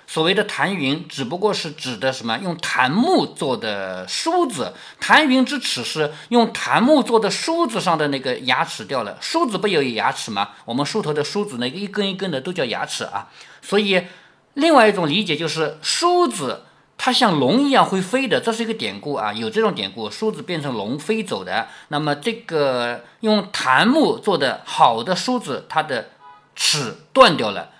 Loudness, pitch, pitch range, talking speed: -19 LUFS, 195 Hz, 150-230 Hz, 270 characters per minute